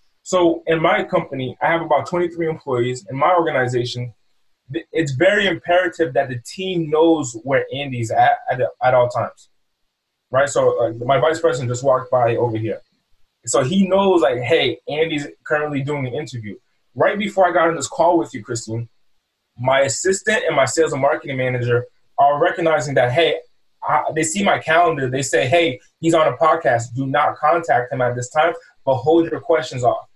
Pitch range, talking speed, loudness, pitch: 125-170 Hz, 185 wpm, -18 LUFS, 150 Hz